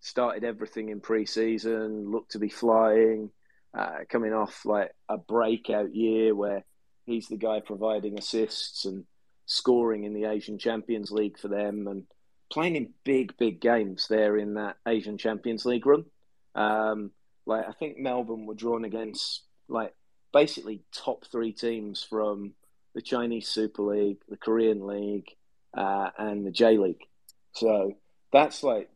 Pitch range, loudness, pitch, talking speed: 105-115 Hz, -28 LUFS, 110 Hz, 150 wpm